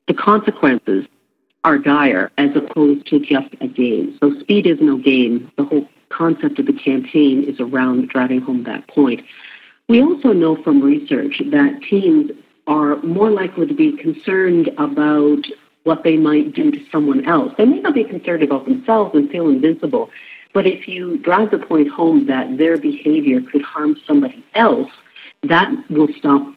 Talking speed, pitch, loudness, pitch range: 170 wpm, 165 Hz, -16 LUFS, 145-240 Hz